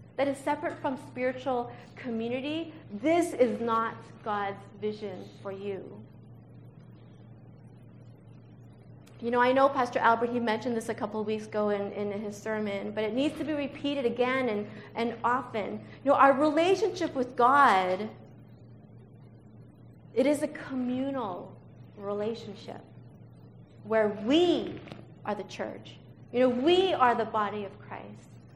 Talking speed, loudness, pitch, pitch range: 135 wpm, -29 LUFS, 240 Hz, 210-275 Hz